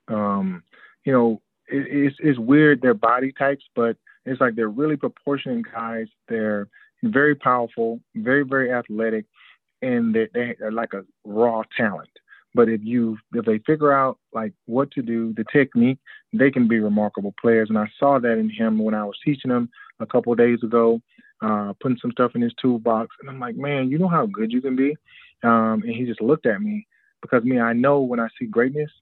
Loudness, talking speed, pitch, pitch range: -21 LUFS, 200 wpm, 120 Hz, 115-140 Hz